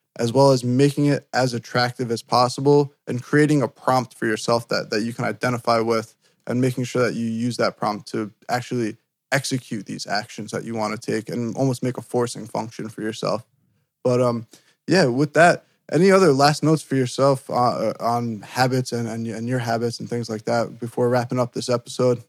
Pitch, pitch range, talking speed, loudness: 125 Hz, 115-135 Hz, 200 wpm, -22 LUFS